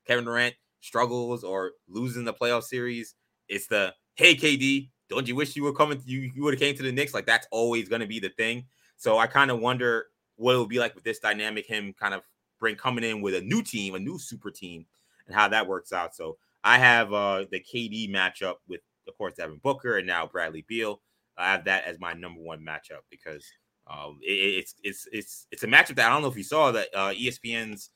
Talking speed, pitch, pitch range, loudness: 235 wpm, 120 Hz, 105-130 Hz, -25 LUFS